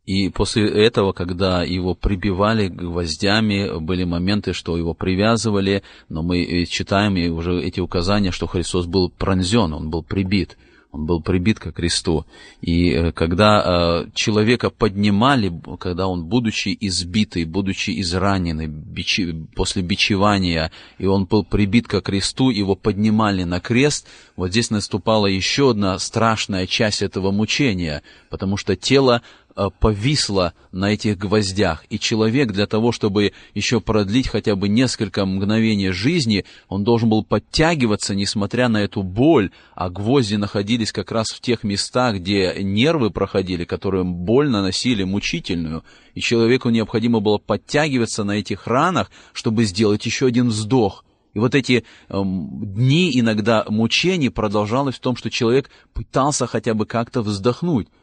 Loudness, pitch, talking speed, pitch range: -19 LUFS, 100 Hz, 140 wpm, 95-115 Hz